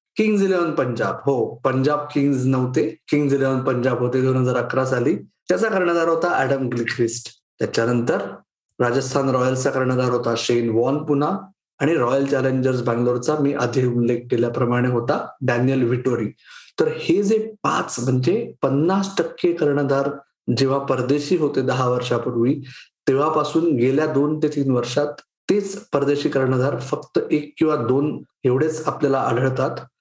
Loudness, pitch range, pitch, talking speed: -21 LUFS, 125-150 Hz, 135 Hz, 135 wpm